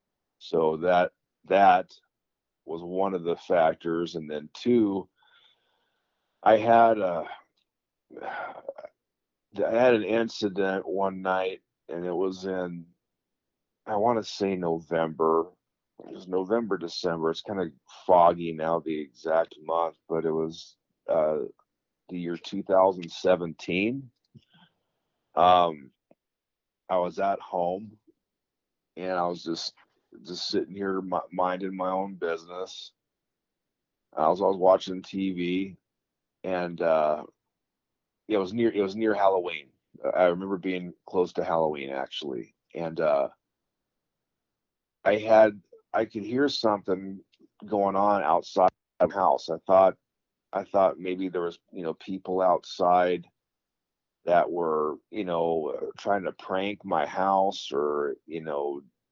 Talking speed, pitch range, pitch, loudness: 125 wpm, 85-95 Hz, 90 Hz, -27 LUFS